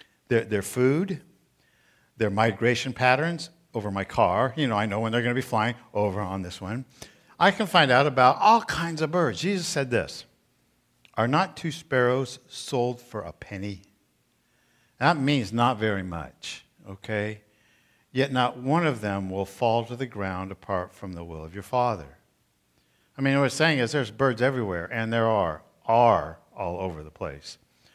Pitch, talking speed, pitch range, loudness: 120 Hz, 175 wpm, 100-135 Hz, -25 LUFS